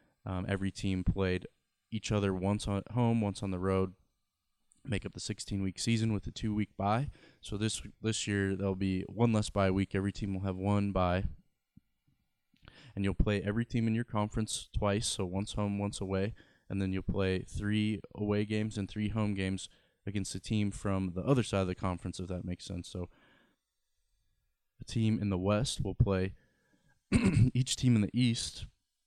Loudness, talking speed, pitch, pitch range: -33 LUFS, 190 wpm, 100 Hz, 95-110 Hz